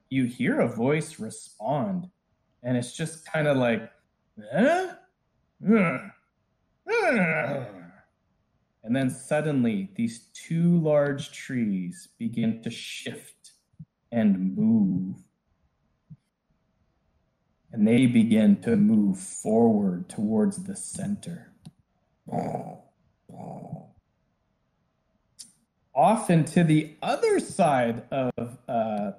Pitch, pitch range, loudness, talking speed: 180 Hz, 135-220 Hz, -25 LUFS, 85 wpm